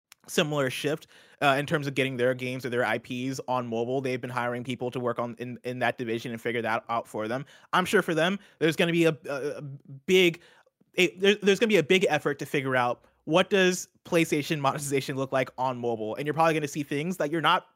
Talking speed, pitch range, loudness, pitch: 245 wpm, 125-165 Hz, -27 LUFS, 140 Hz